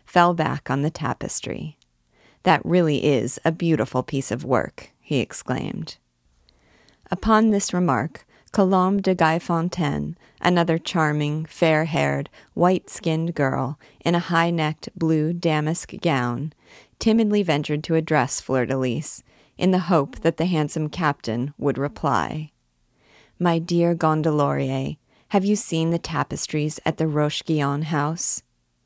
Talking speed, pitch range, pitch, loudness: 120 wpm, 135-170 Hz, 155 Hz, -22 LUFS